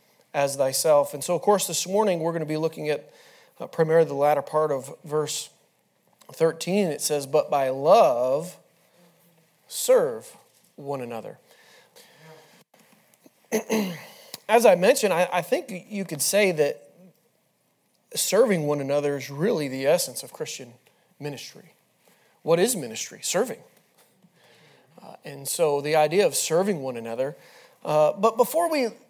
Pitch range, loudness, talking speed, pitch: 150-205 Hz, -24 LUFS, 140 wpm, 165 Hz